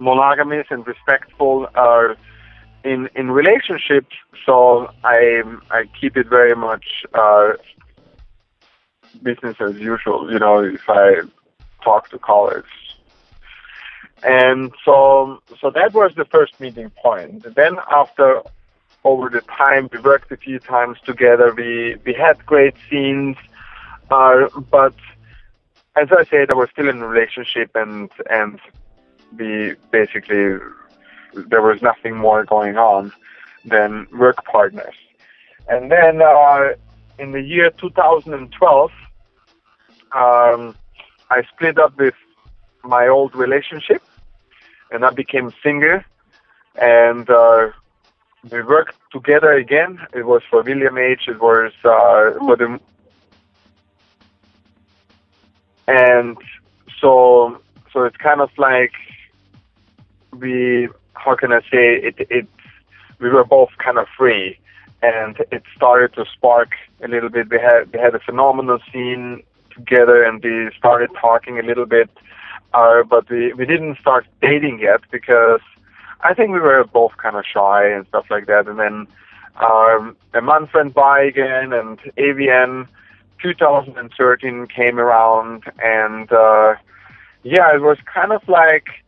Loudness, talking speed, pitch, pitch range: -14 LUFS, 130 wpm, 120 Hz, 110-135 Hz